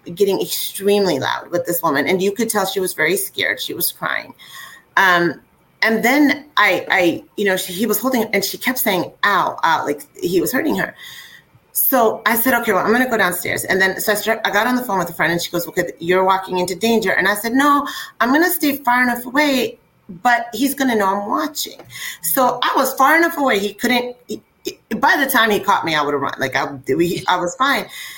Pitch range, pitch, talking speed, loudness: 190-265 Hz, 225 Hz, 235 wpm, -17 LUFS